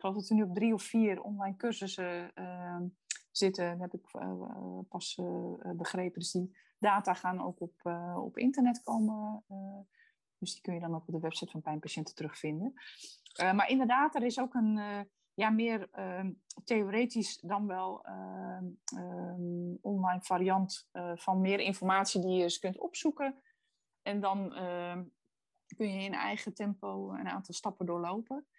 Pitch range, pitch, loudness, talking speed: 175-215 Hz, 190 Hz, -35 LUFS, 175 wpm